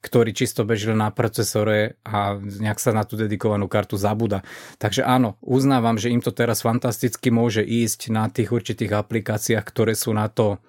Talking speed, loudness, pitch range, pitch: 175 wpm, -22 LUFS, 105-120 Hz, 115 Hz